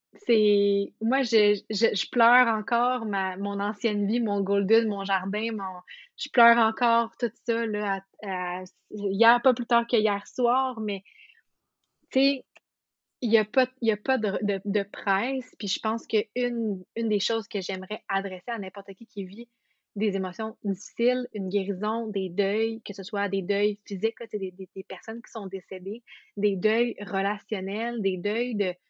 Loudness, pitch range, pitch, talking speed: -26 LUFS, 200-230 Hz, 210 Hz, 180 wpm